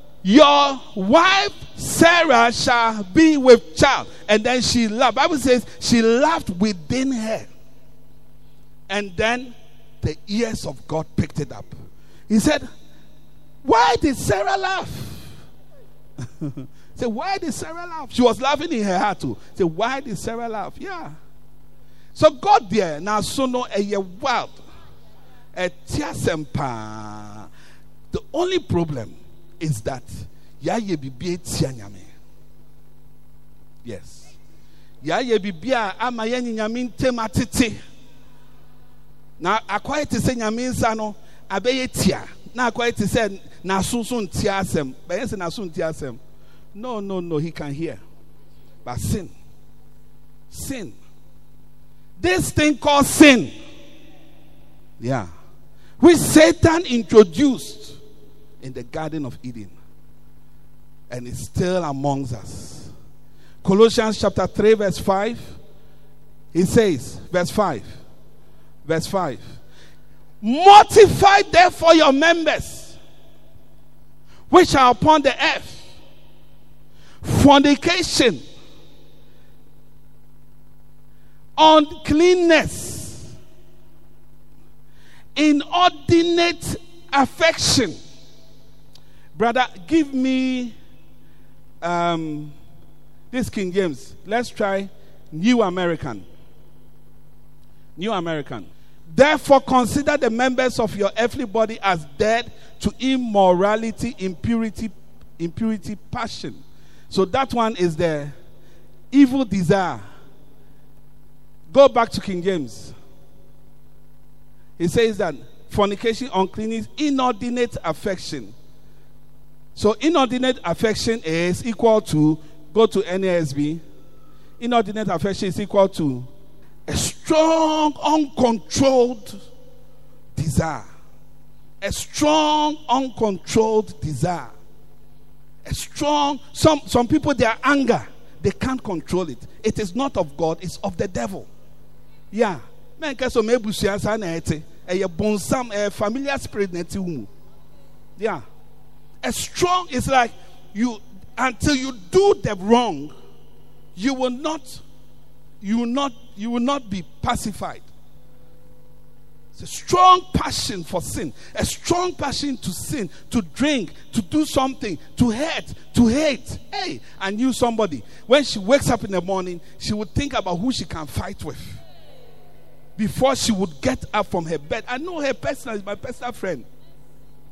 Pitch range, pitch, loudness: 170-260 Hz, 220 Hz, -19 LUFS